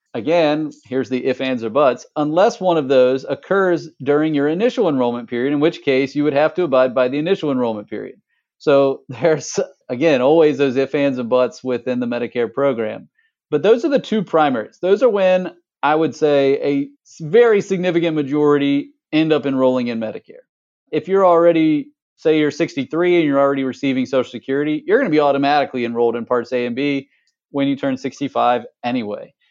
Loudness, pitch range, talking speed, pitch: -18 LUFS, 130-165 Hz, 185 wpm, 140 Hz